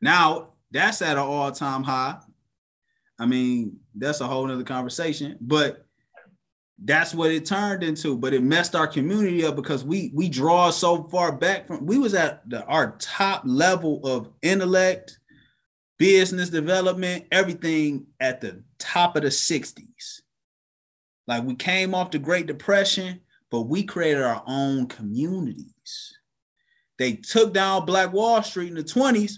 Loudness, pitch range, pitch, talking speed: -23 LUFS, 145-190 Hz, 170 Hz, 150 wpm